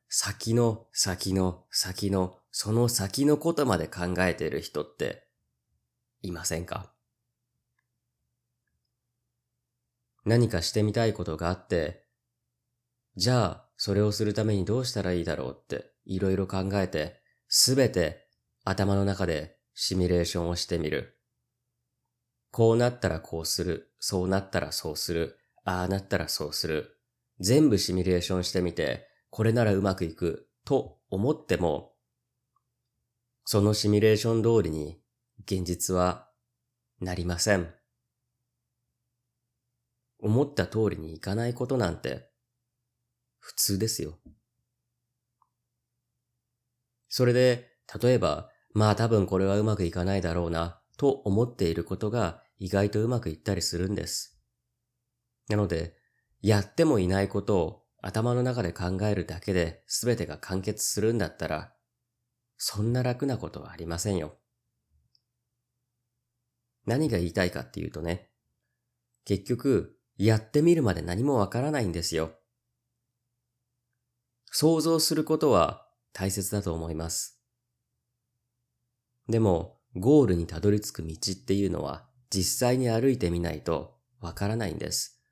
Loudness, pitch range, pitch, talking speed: -28 LUFS, 90-120 Hz, 110 Hz, 260 characters per minute